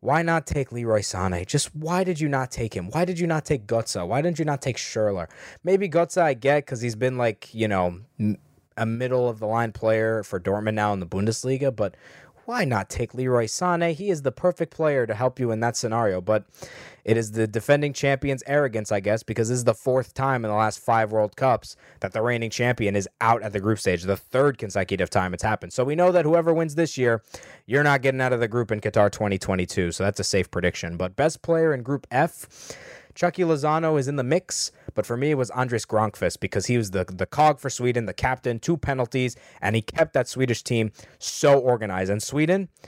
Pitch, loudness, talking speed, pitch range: 120 Hz, -24 LUFS, 230 wpm, 105-145 Hz